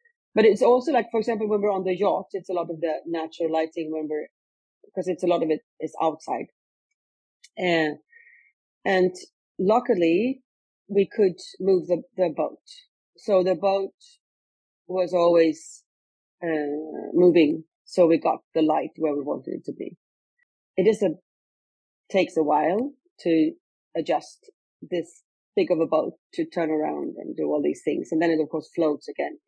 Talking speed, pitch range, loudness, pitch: 170 wpm, 160-200 Hz, -24 LUFS, 175 Hz